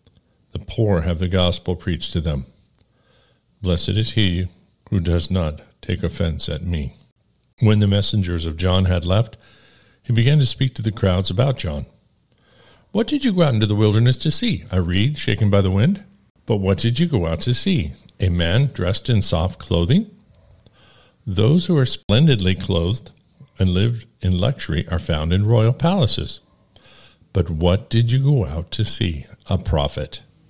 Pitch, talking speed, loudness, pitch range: 100 Hz, 175 wpm, -20 LUFS, 90-125 Hz